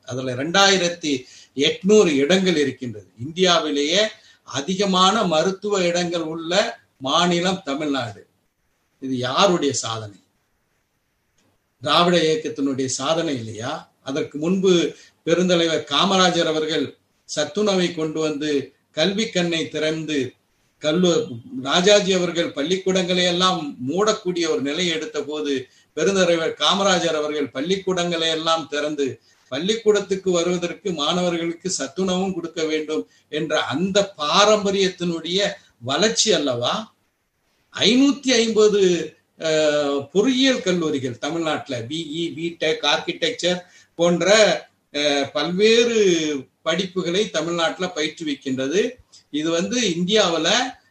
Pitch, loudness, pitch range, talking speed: 165 Hz, -20 LUFS, 150-185 Hz, 85 wpm